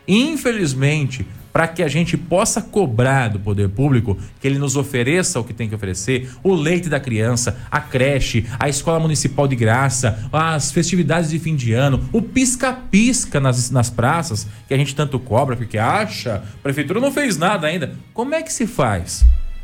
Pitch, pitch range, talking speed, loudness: 140 Hz, 120-170 Hz, 180 wpm, -18 LUFS